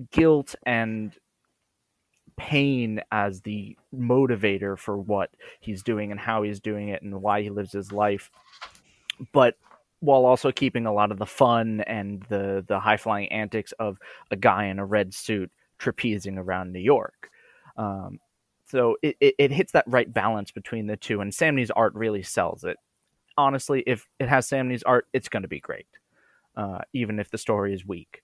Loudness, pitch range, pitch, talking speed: -25 LUFS, 100-125 Hz, 105 Hz, 175 wpm